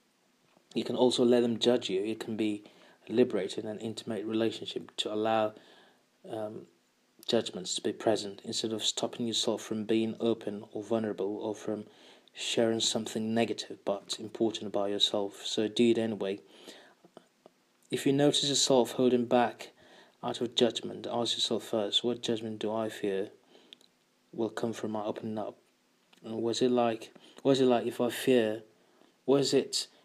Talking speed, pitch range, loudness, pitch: 155 wpm, 110-120 Hz, -31 LUFS, 115 Hz